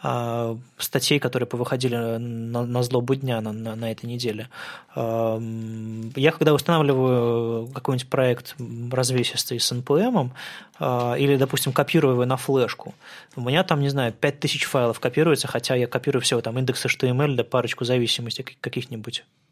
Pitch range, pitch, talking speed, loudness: 115-135 Hz, 125 Hz, 140 wpm, -23 LUFS